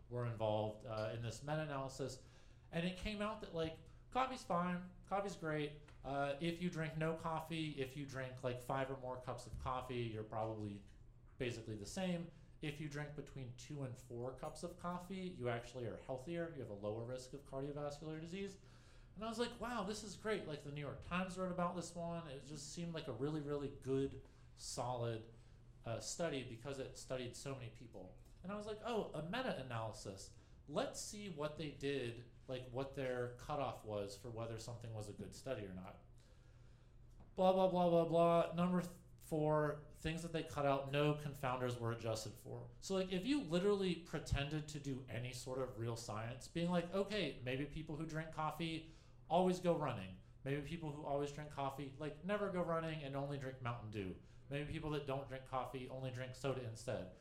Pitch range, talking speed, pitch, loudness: 120-165 Hz, 195 wpm, 140 Hz, -44 LUFS